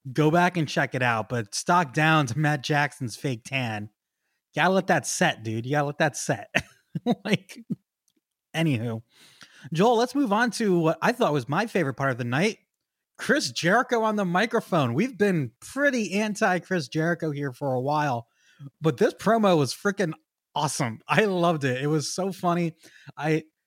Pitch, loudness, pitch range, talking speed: 160 Hz, -25 LUFS, 140-195 Hz, 175 wpm